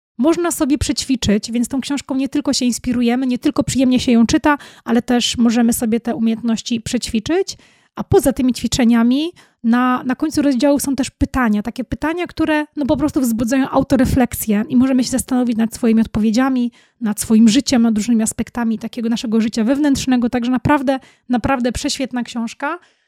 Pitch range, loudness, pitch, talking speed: 235-275 Hz, -17 LUFS, 250 Hz, 165 wpm